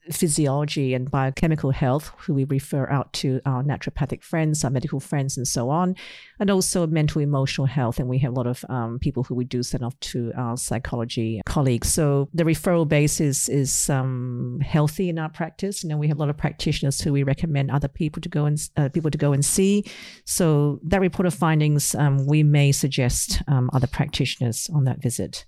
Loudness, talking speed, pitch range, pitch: -23 LUFS, 210 wpm, 130-160 Hz, 145 Hz